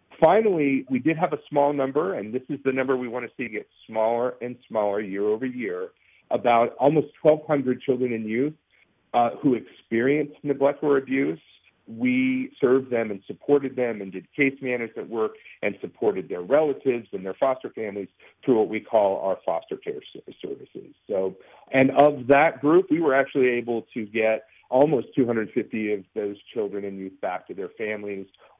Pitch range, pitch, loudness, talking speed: 115-155 Hz, 135 Hz, -24 LUFS, 175 wpm